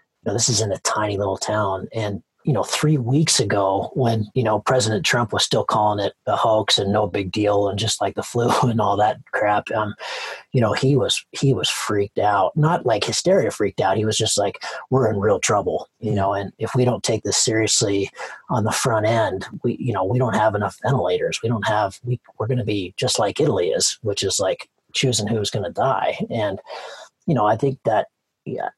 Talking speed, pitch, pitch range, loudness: 225 wpm, 110 Hz, 100-125 Hz, -20 LUFS